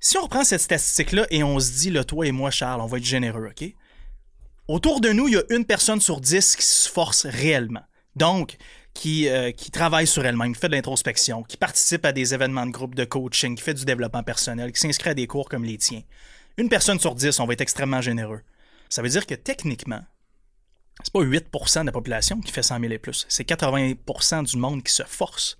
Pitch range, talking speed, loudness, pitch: 125-165 Hz, 230 wpm, -21 LUFS, 135 Hz